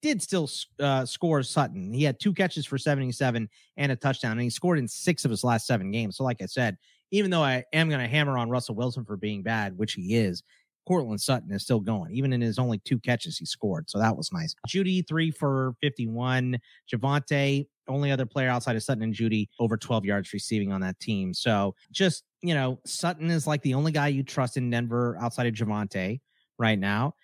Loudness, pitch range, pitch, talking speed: -27 LUFS, 115-145 Hz, 125 Hz, 220 wpm